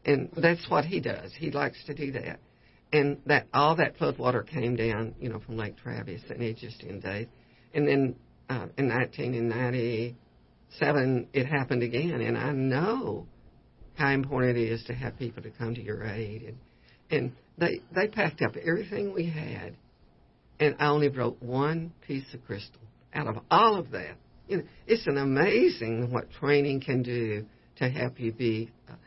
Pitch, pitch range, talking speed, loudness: 120 Hz, 115-140 Hz, 180 wpm, -29 LUFS